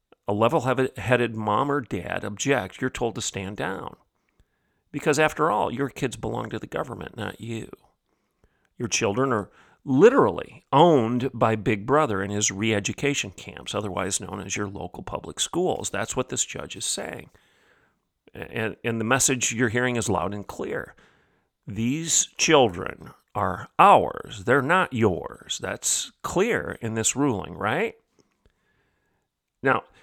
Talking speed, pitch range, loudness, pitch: 145 wpm, 105-135 Hz, -24 LUFS, 115 Hz